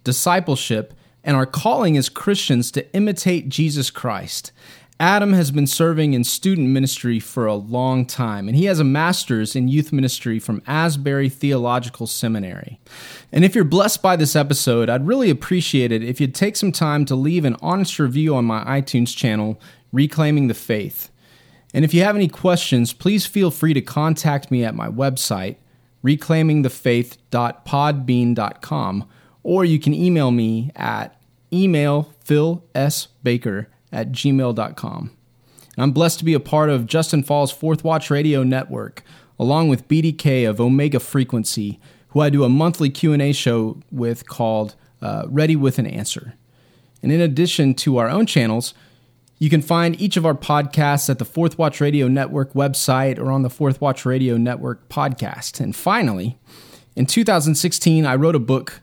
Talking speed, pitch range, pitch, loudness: 160 wpm, 125-160 Hz, 140 Hz, -19 LUFS